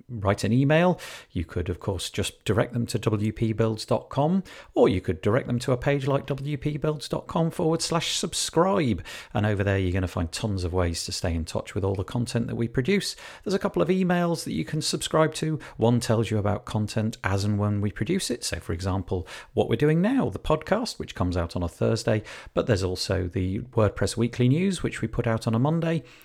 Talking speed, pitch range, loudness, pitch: 220 wpm, 100-150 Hz, -26 LUFS, 115 Hz